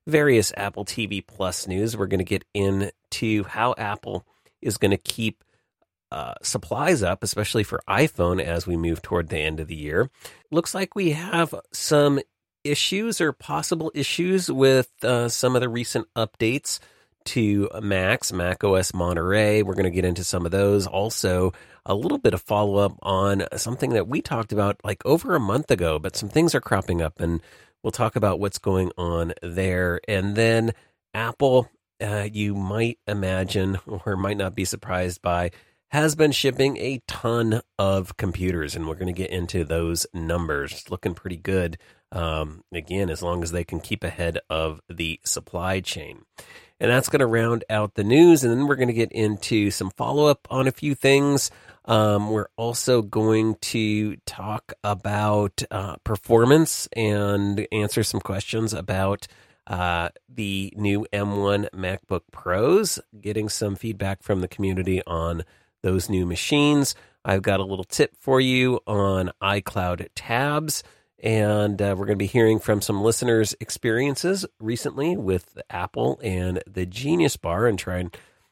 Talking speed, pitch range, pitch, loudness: 170 wpm, 95-115 Hz, 105 Hz, -23 LUFS